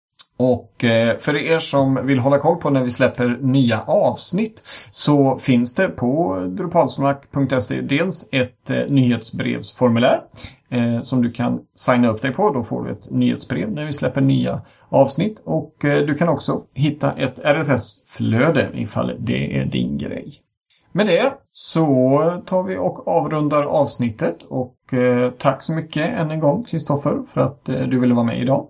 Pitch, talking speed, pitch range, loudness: 135 Hz, 155 wpm, 120-150 Hz, -19 LUFS